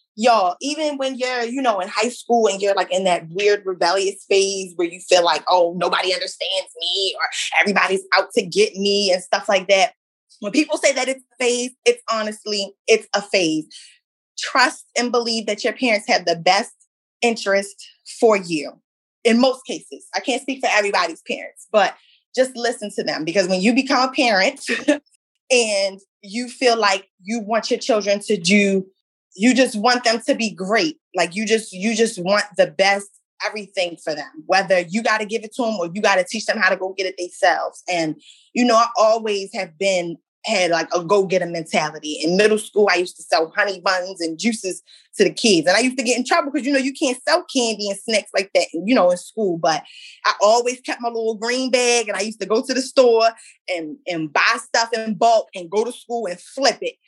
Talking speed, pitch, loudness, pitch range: 215 wpm, 215 Hz, -19 LUFS, 190-245 Hz